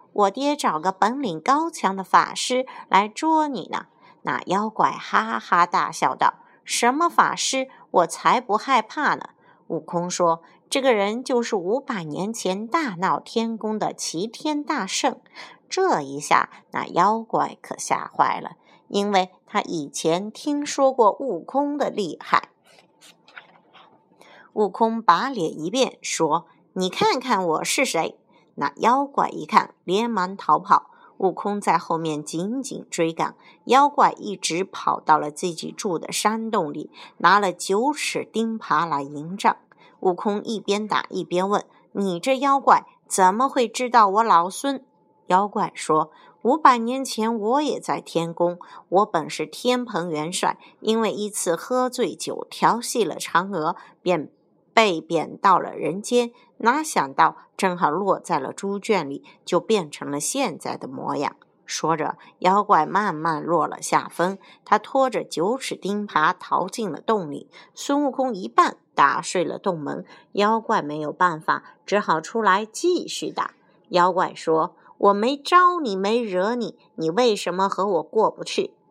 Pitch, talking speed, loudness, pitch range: 210 Hz, 210 characters per minute, -22 LUFS, 180-260 Hz